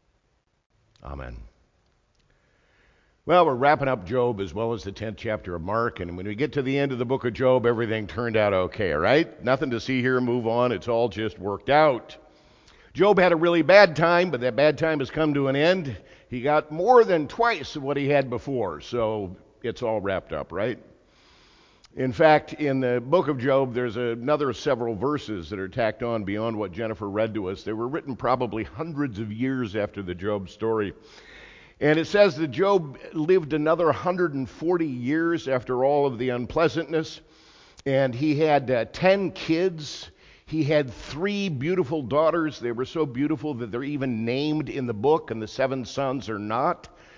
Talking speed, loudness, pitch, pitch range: 185 wpm, -24 LUFS, 130 Hz, 115-155 Hz